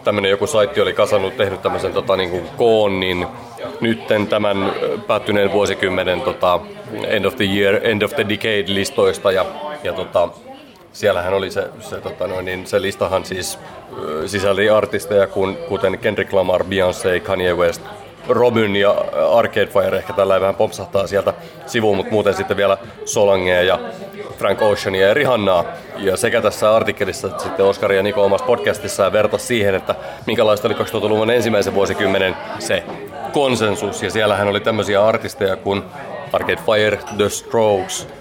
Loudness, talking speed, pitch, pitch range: -17 LUFS, 155 wpm, 100 Hz, 95-110 Hz